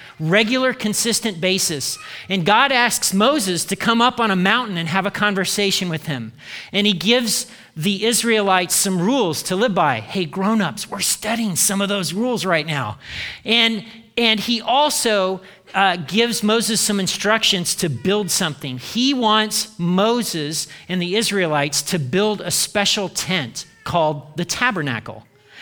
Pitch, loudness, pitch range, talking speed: 195 Hz, -18 LUFS, 175-220 Hz, 150 wpm